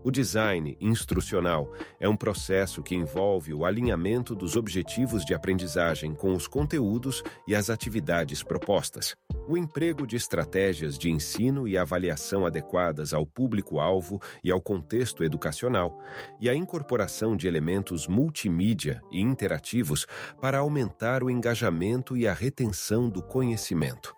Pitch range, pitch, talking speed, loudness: 90-125 Hz, 100 Hz, 130 wpm, -28 LUFS